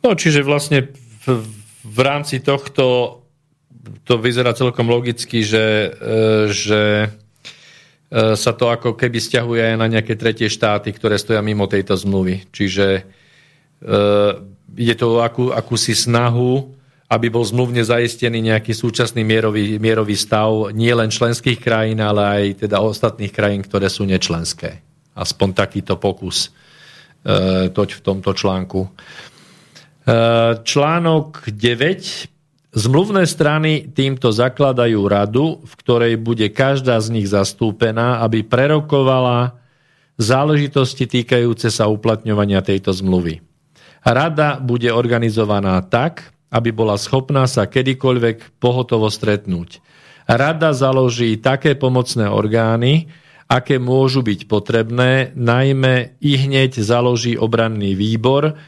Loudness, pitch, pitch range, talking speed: -16 LUFS, 115 Hz, 105-130 Hz, 110 wpm